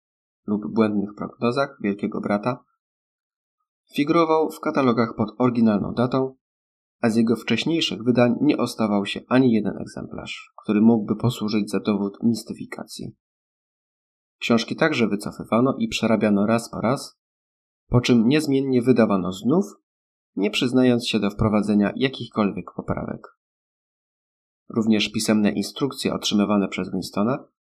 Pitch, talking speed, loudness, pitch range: 110 Hz, 115 wpm, -22 LUFS, 100-125 Hz